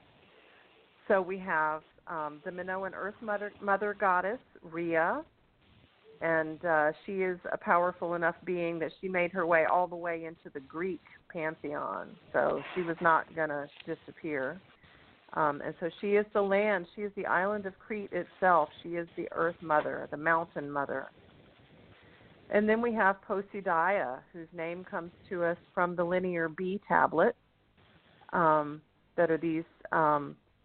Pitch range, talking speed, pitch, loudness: 160-190 Hz, 155 wpm, 175 Hz, -31 LUFS